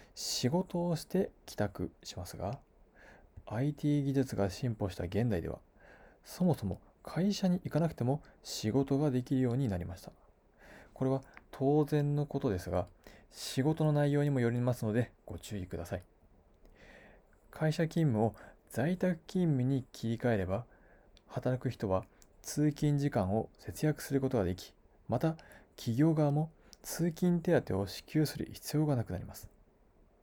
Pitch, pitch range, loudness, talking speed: 130 Hz, 100-150 Hz, -34 LUFS, 280 characters per minute